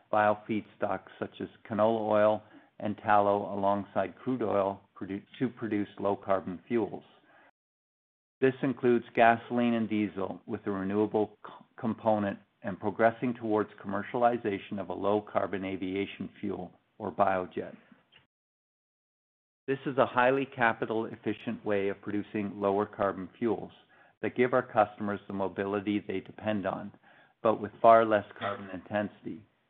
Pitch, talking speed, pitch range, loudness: 105 Hz, 130 wpm, 100-115 Hz, -30 LUFS